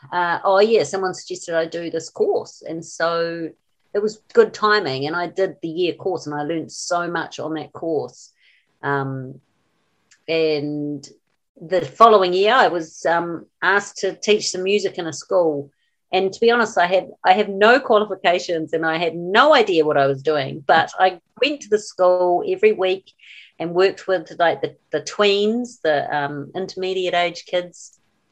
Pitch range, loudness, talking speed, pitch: 160-195 Hz, -19 LUFS, 180 wpm, 175 Hz